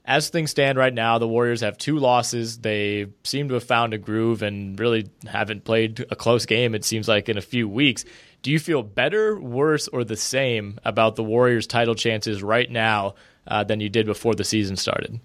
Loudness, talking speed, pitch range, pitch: -22 LUFS, 210 wpm, 110-125 Hz, 115 Hz